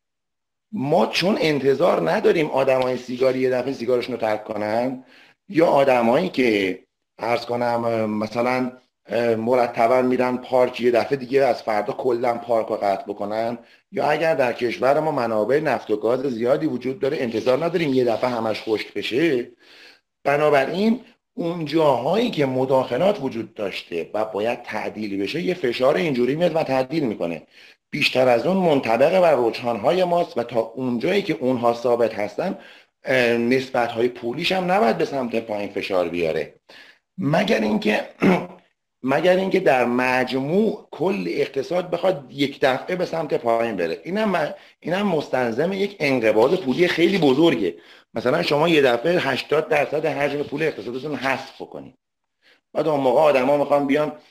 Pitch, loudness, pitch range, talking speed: 130 Hz, -21 LUFS, 120-150 Hz, 150 wpm